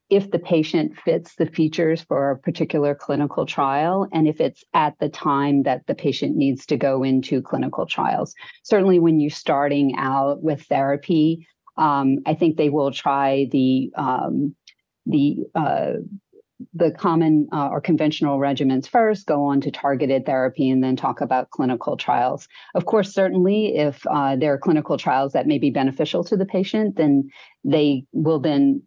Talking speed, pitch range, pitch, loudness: 170 wpm, 140-175 Hz, 150 Hz, -21 LUFS